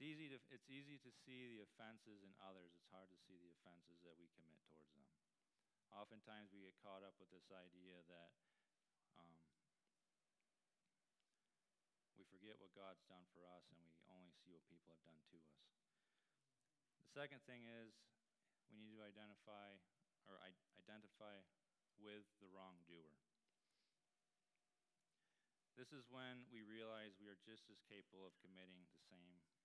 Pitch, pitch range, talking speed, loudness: 95 Hz, 90-110 Hz, 155 wpm, -63 LUFS